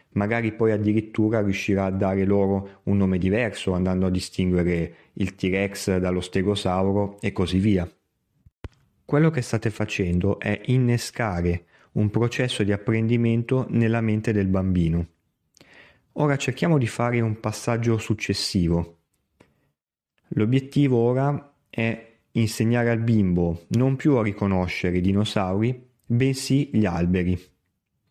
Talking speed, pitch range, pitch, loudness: 120 wpm, 95-115 Hz, 105 Hz, -23 LUFS